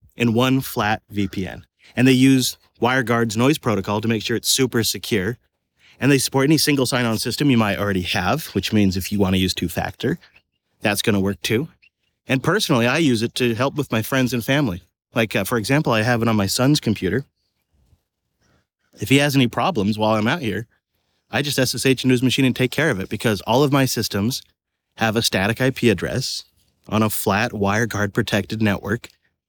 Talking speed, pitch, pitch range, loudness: 205 wpm, 115 Hz, 100-130 Hz, -20 LUFS